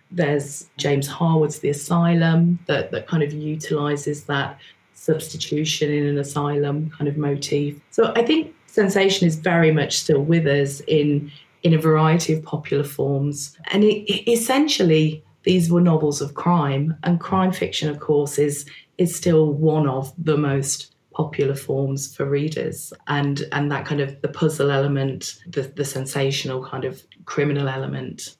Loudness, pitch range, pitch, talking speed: -21 LUFS, 140-165 Hz, 150 Hz, 160 wpm